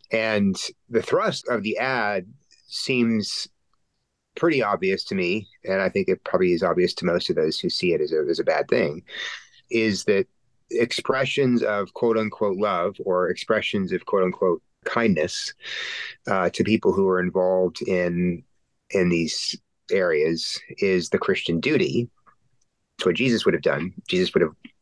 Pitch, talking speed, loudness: 115 Hz, 160 wpm, -23 LUFS